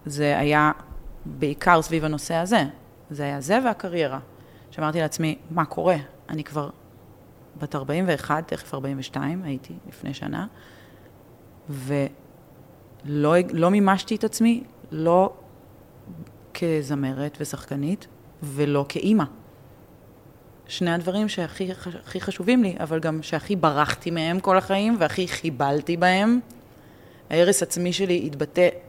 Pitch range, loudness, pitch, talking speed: 145-180 Hz, -24 LUFS, 160 Hz, 110 wpm